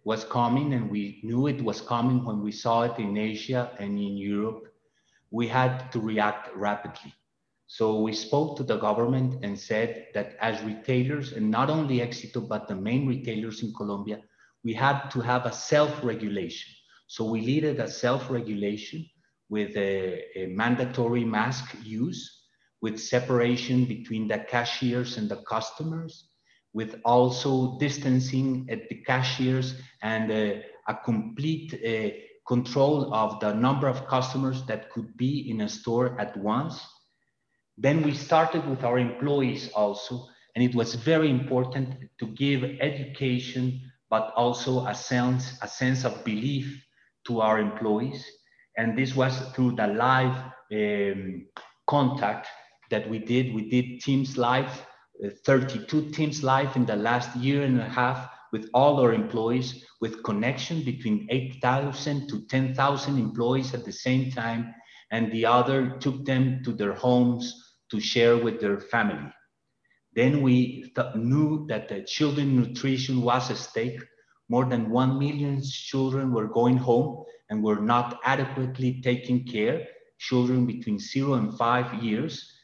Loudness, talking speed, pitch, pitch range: -27 LUFS, 150 wpm, 125 Hz, 110-130 Hz